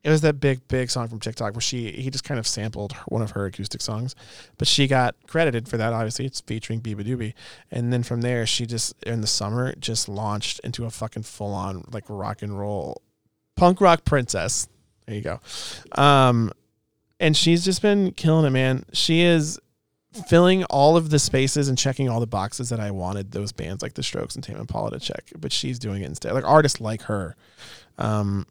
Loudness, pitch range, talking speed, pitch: -23 LUFS, 105-140 Hz, 210 wpm, 120 Hz